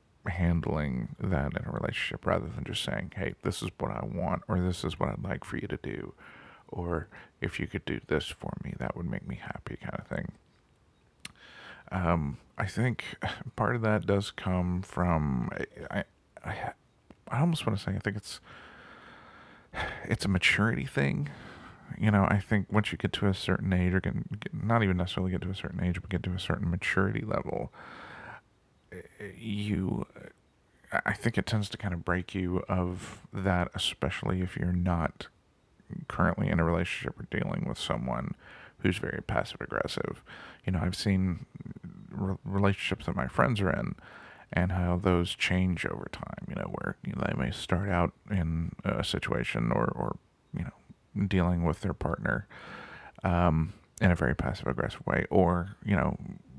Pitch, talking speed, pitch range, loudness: 95 Hz, 180 wpm, 90-100 Hz, -31 LUFS